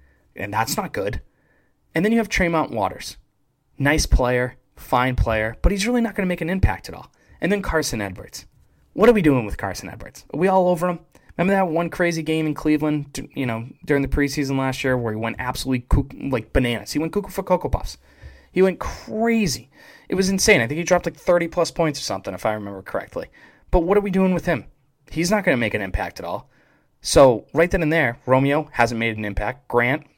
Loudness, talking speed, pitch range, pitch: -21 LUFS, 225 wpm, 120-180 Hz, 150 Hz